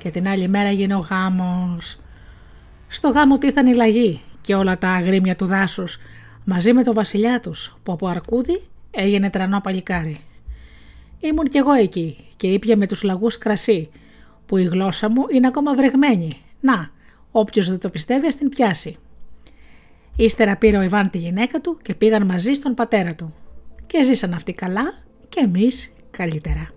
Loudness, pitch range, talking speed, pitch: -19 LUFS, 175-235 Hz, 165 wpm, 195 Hz